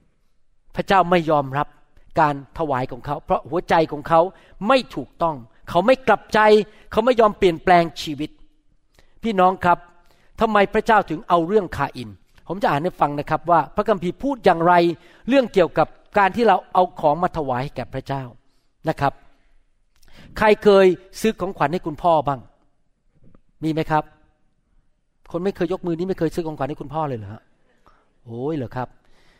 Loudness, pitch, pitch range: -20 LUFS, 165 Hz, 145-185 Hz